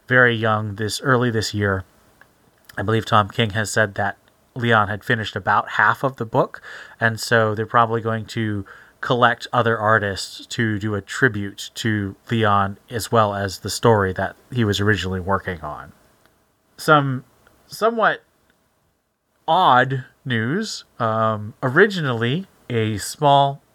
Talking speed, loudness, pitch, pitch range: 140 wpm, -20 LUFS, 110 Hz, 105-120 Hz